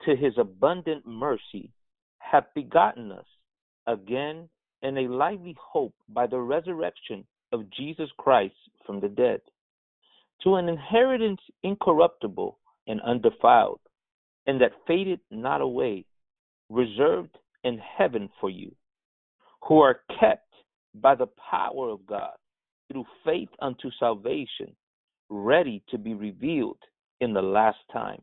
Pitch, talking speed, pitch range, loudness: 150 Hz, 120 wpm, 120-195 Hz, -26 LUFS